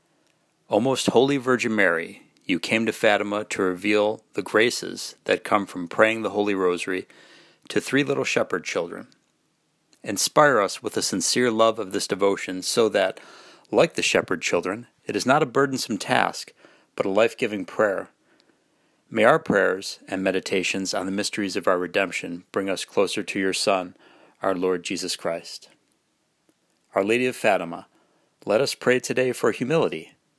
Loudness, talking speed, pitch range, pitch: -23 LUFS, 160 wpm, 95-120 Hz, 105 Hz